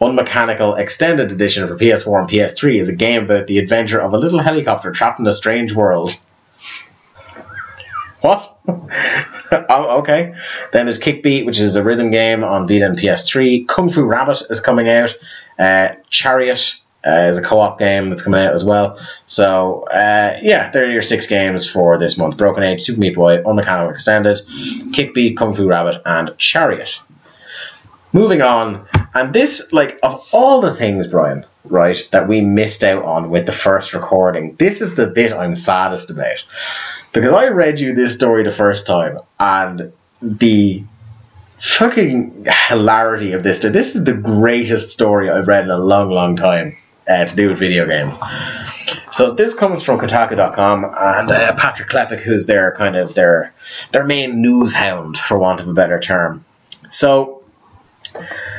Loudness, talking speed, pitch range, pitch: -14 LUFS, 170 wpm, 95-120 Hz, 105 Hz